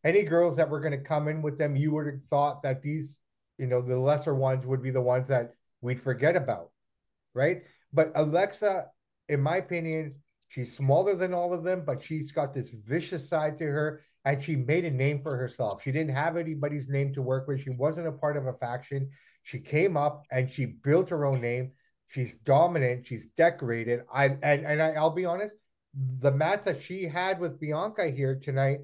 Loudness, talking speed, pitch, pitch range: -28 LUFS, 210 wpm, 145 Hz, 130-160 Hz